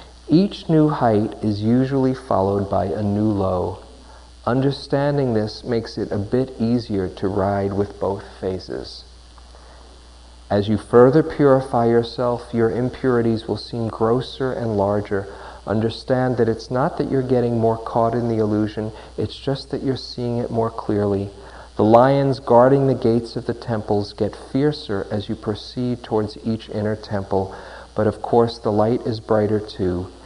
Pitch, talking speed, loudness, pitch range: 115 Hz, 155 wpm, -20 LUFS, 100-125 Hz